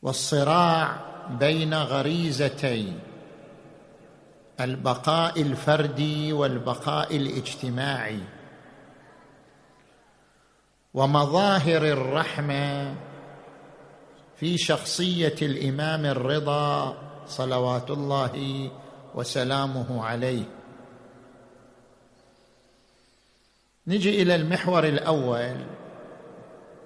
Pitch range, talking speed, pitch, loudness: 130-155 Hz, 45 wpm, 140 Hz, -25 LUFS